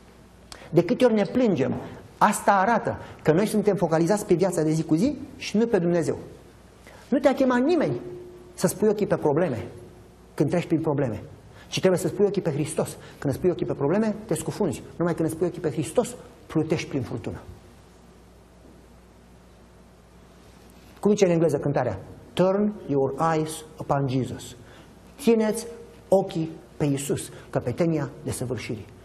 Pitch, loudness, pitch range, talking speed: 160 Hz, -25 LUFS, 130-195 Hz, 155 wpm